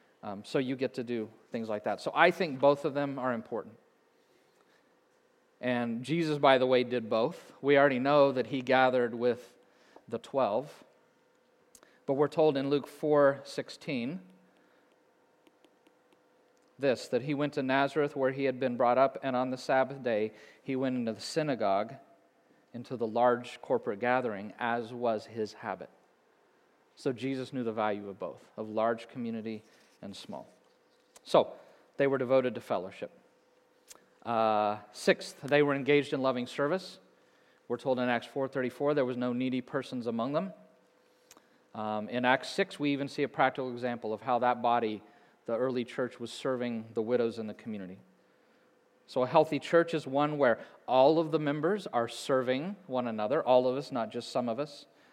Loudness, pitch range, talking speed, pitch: -31 LUFS, 115-140 Hz, 170 wpm, 130 Hz